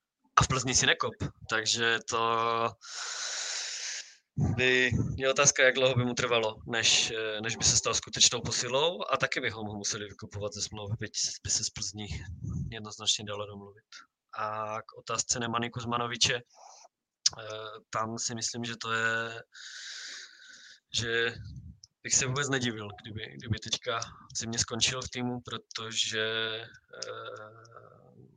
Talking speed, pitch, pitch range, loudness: 125 wpm, 115 Hz, 110-130 Hz, -29 LUFS